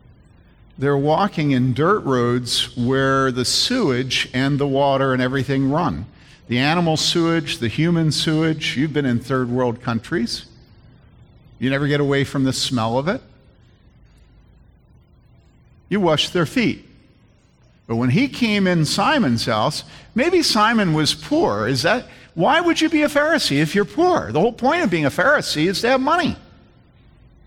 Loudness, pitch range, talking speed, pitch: -19 LUFS, 130-195 Hz, 155 wpm, 145 Hz